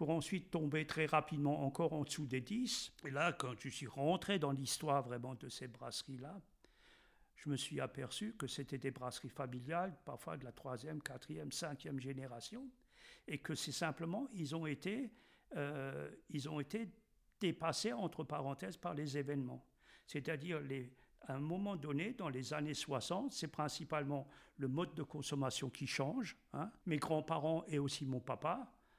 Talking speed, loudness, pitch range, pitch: 165 wpm, -43 LUFS, 135-165 Hz, 150 Hz